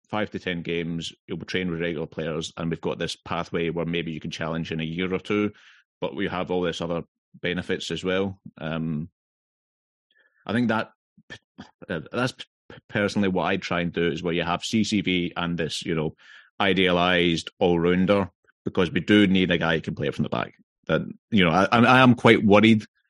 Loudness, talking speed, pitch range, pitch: -24 LUFS, 200 wpm, 85-100 Hz, 90 Hz